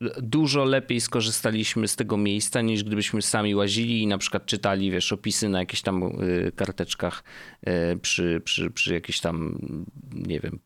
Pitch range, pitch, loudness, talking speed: 95-115 Hz, 105 Hz, -25 LUFS, 150 wpm